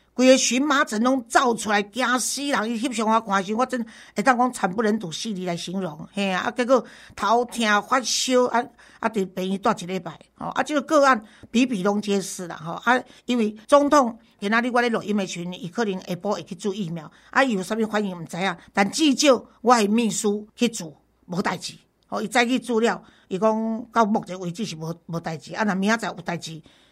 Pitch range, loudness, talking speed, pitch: 195-245 Hz, -23 LUFS, 310 characters per minute, 220 Hz